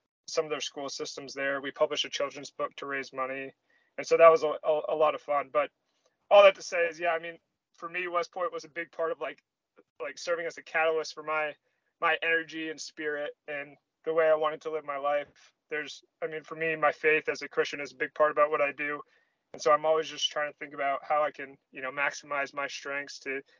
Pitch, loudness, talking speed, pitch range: 150 Hz, -29 LUFS, 250 wpm, 140-160 Hz